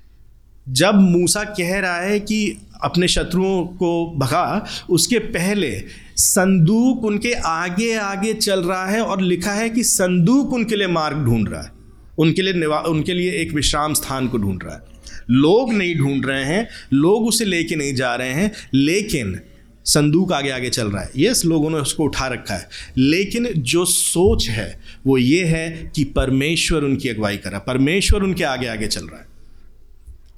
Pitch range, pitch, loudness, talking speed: 130-190 Hz, 165 Hz, -18 LUFS, 170 wpm